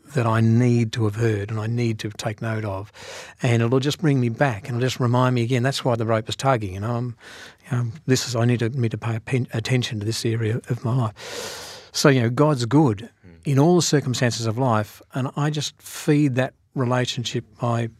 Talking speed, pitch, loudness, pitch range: 235 wpm, 120 Hz, -22 LUFS, 115-135 Hz